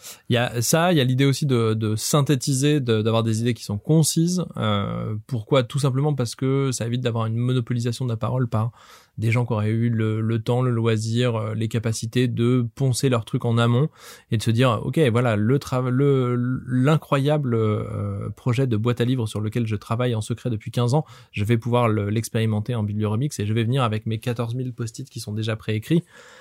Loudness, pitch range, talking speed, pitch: -22 LUFS, 110-130 Hz, 220 wpm, 120 Hz